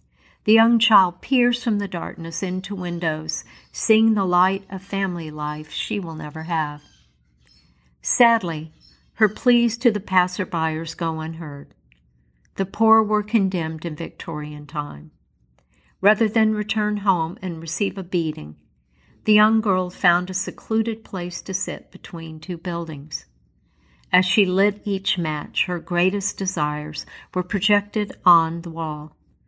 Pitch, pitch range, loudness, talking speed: 175 Hz, 150-200 Hz, -22 LUFS, 135 wpm